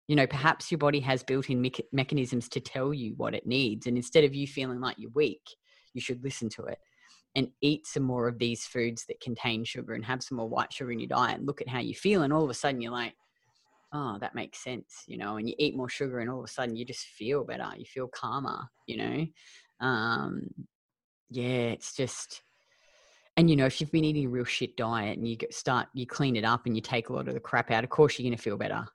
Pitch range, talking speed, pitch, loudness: 120-140 Hz, 255 wpm, 125 Hz, -31 LUFS